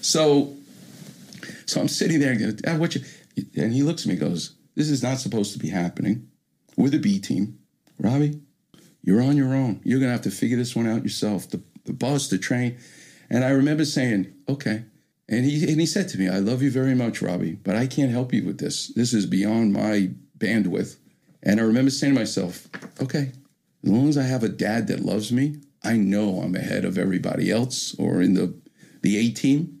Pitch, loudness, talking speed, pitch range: 130 Hz, -23 LUFS, 205 wpm, 110-145 Hz